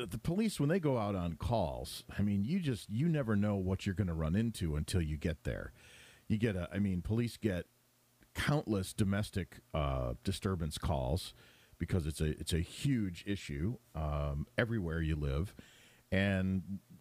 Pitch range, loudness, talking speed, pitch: 85-115 Hz, -36 LUFS, 175 wpm, 100 Hz